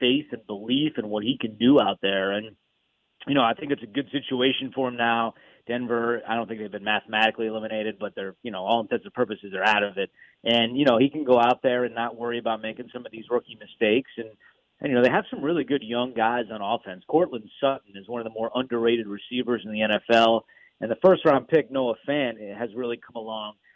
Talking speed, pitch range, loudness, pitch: 240 wpm, 110-125 Hz, -25 LUFS, 115 Hz